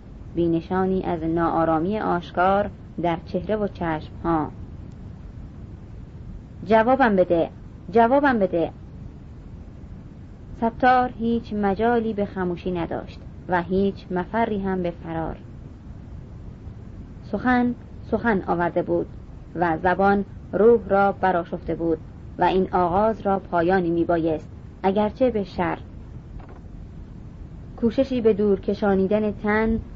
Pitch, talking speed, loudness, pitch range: 185 Hz, 100 wpm, -23 LUFS, 165-210 Hz